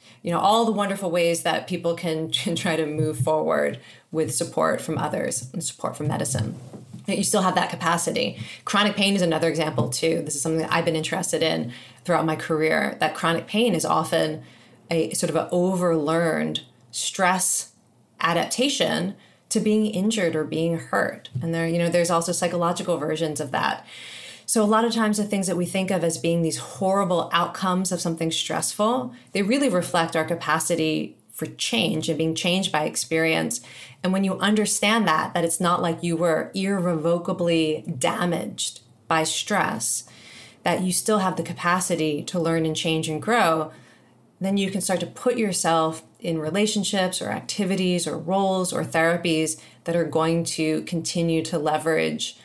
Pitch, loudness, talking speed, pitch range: 170 Hz, -23 LUFS, 175 wpm, 160-185 Hz